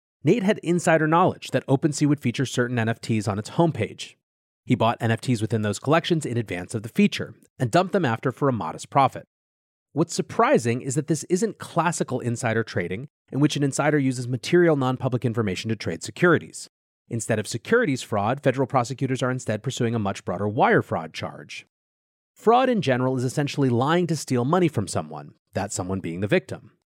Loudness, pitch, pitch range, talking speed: -24 LUFS, 130 Hz, 110-150 Hz, 185 wpm